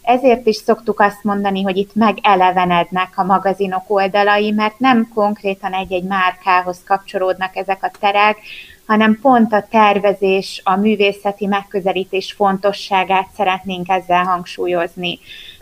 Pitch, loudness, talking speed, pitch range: 195 Hz, -16 LUFS, 120 wpm, 190-205 Hz